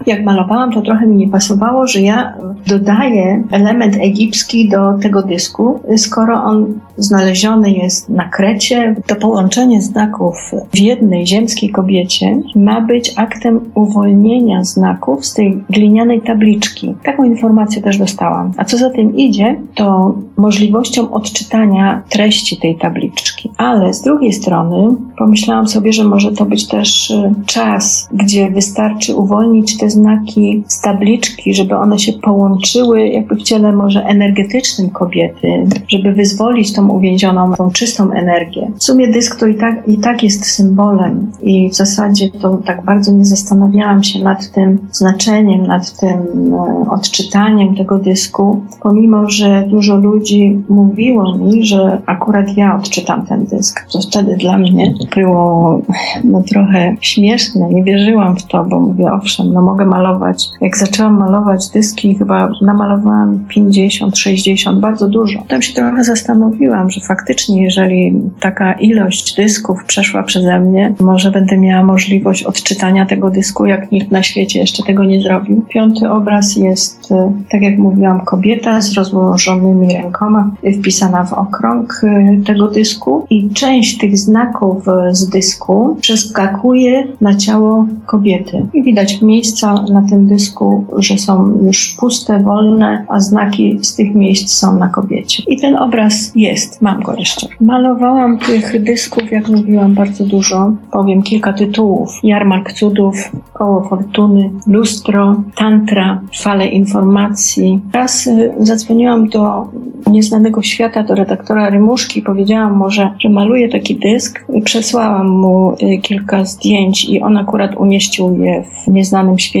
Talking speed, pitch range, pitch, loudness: 140 wpm, 195-220 Hz, 205 Hz, -10 LUFS